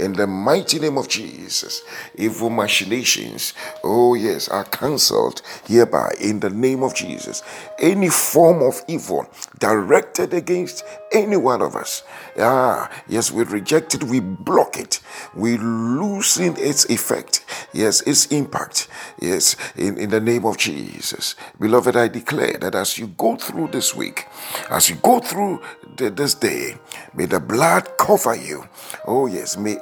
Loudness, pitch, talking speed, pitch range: -19 LUFS, 125 Hz, 155 wpm, 110-160 Hz